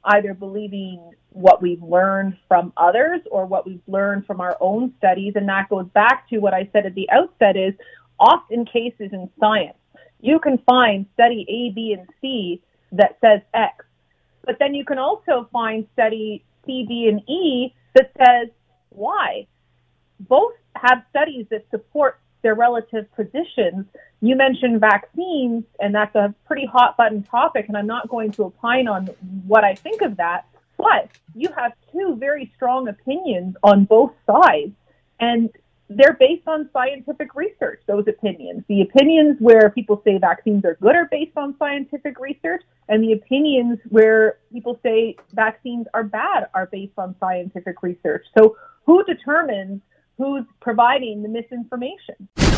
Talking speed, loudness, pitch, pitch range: 155 wpm, -18 LUFS, 230 Hz, 205-270 Hz